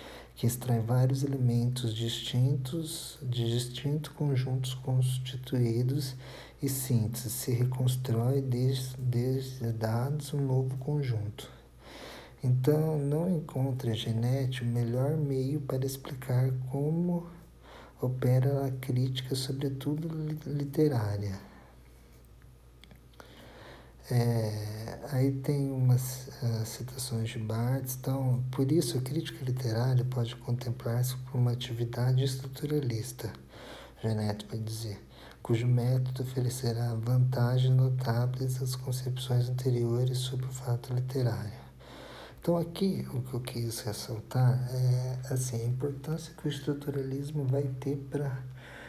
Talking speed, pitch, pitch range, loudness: 105 wpm, 130 Hz, 120-135 Hz, -31 LUFS